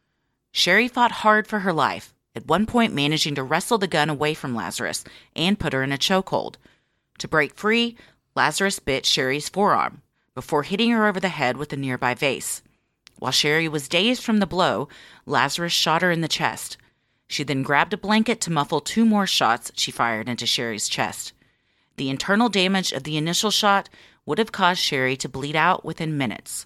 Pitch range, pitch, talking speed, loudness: 140-200 Hz, 160 Hz, 190 wpm, -22 LUFS